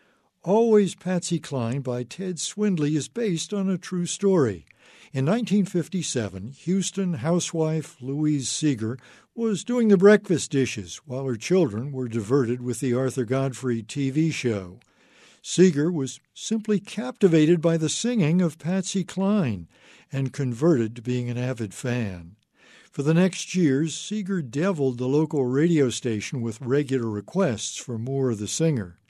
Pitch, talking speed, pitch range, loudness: 150 Hz, 140 wpm, 125-185 Hz, -24 LUFS